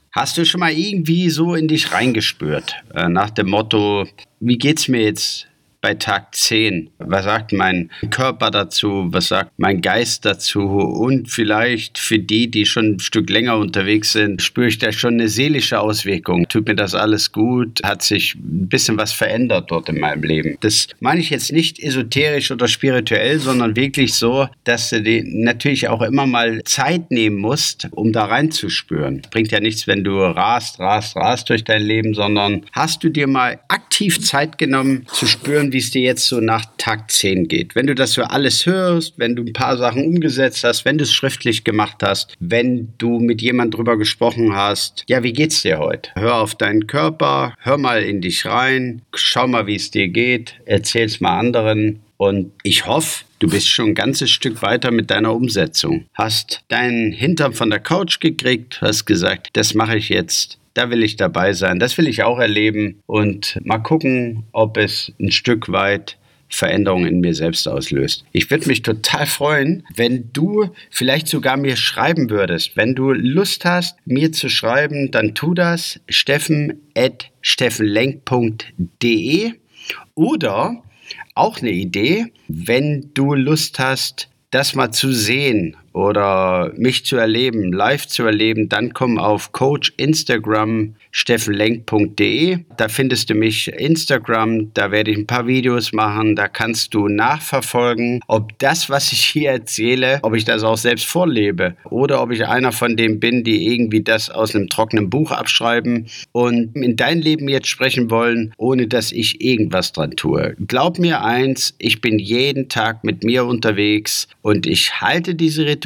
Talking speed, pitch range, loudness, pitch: 175 wpm, 110-135 Hz, -16 LUFS, 120 Hz